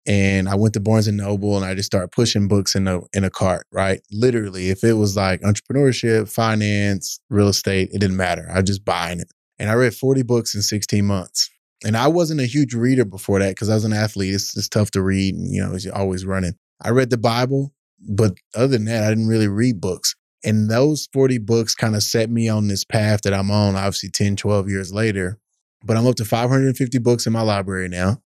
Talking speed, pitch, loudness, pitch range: 235 wpm, 105 Hz, -19 LUFS, 95-115 Hz